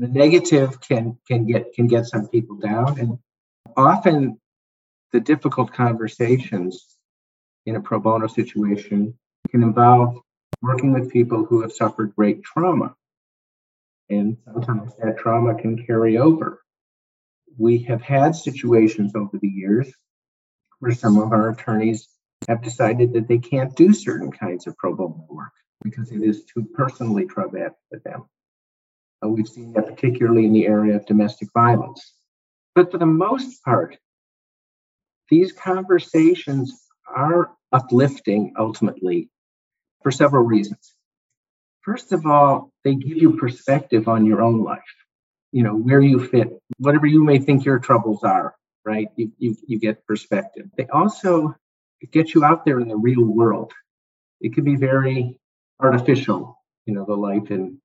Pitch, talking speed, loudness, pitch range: 120 Hz, 145 wpm, -19 LUFS, 110-140 Hz